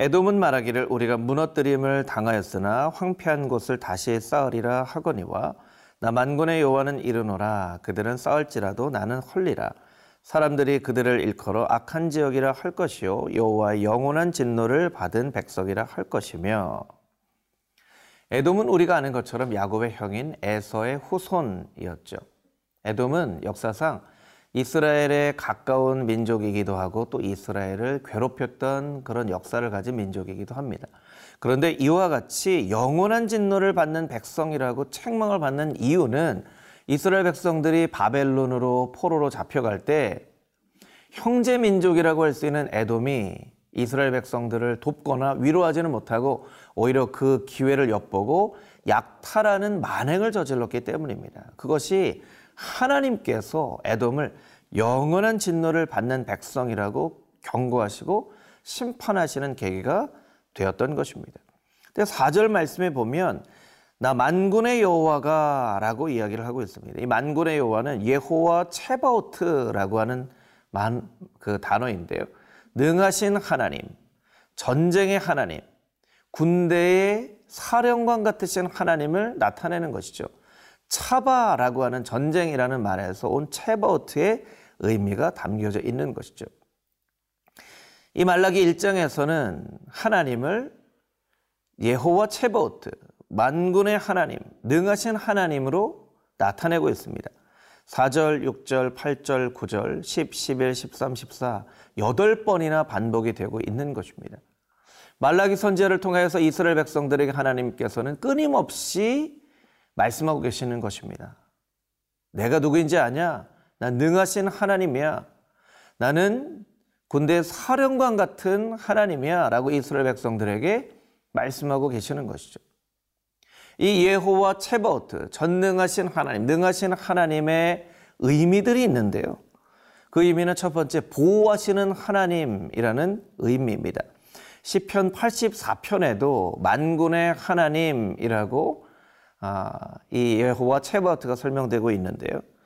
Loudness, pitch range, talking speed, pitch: -24 LUFS, 120-185 Hz, 280 characters per minute, 145 Hz